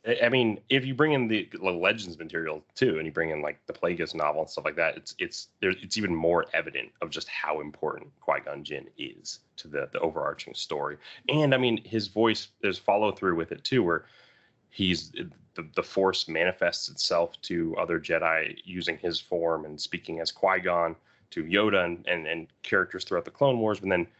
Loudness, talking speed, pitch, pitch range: -28 LUFS, 205 wpm, 105 Hz, 85-125 Hz